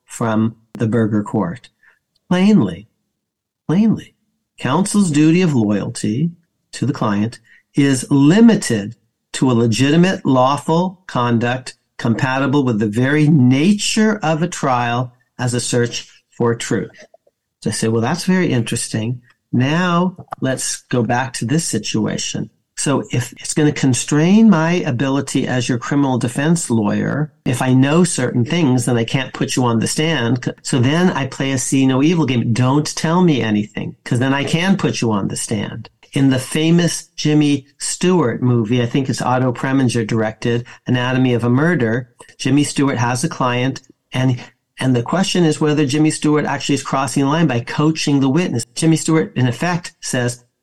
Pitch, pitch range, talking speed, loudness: 135 Hz, 120-155 Hz, 165 wpm, -17 LUFS